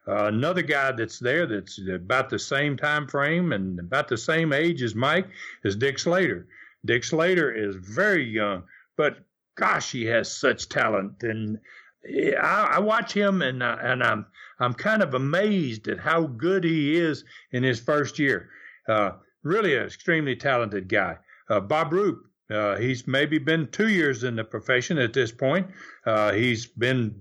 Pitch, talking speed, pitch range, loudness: 130 Hz, 170 wpm, 115-165 Hz, -24 LUFS